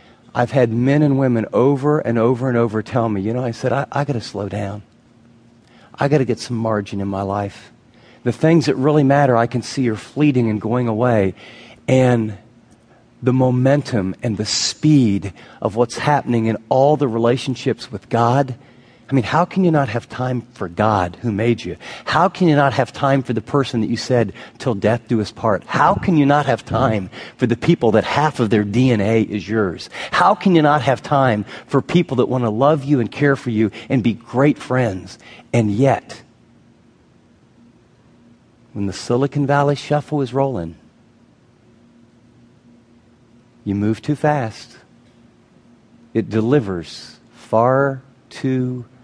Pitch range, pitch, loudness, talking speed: 115-135 Hz, 120 Hz, -18 LUFS, 175 wpm